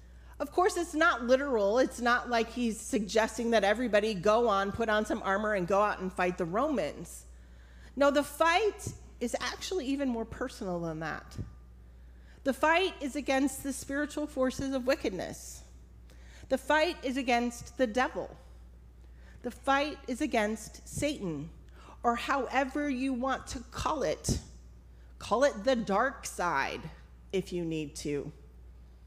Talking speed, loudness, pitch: 145 wpm, -31 LUFS, 230 Hz